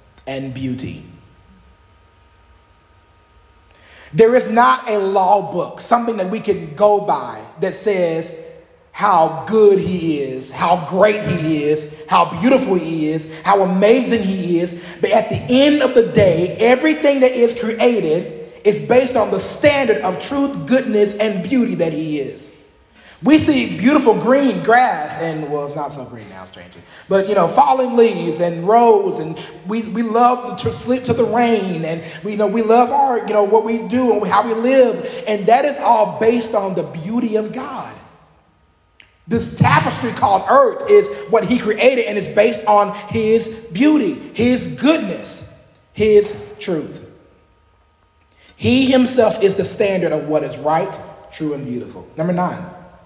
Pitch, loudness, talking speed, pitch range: 205 Hz, -16 LUFS, 160 wpm, 160-235 Hz